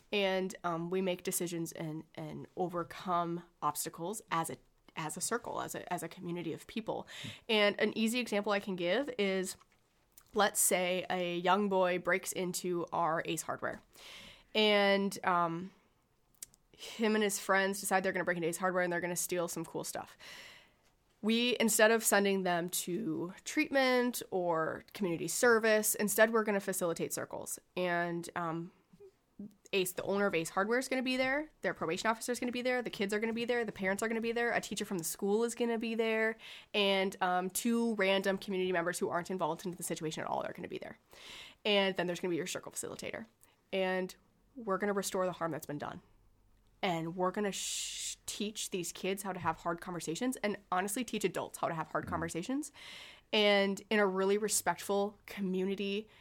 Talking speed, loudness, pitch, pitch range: 200 wpm, -34 LUFS, 190 Hz, 175-210 Hz